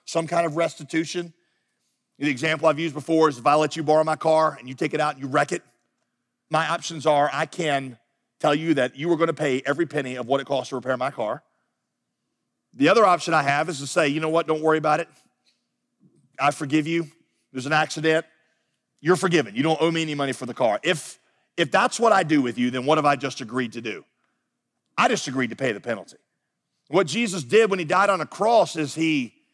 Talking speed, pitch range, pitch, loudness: 235 wpm, 145-165 Hz, 155 Hz, -23 LUFS